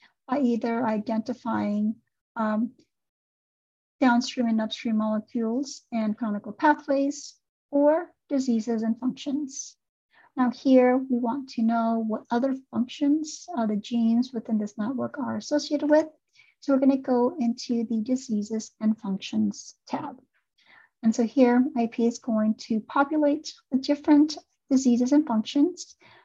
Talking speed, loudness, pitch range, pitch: 130 wpm, -26 LUFS, 225-285 Hz, 245 Hz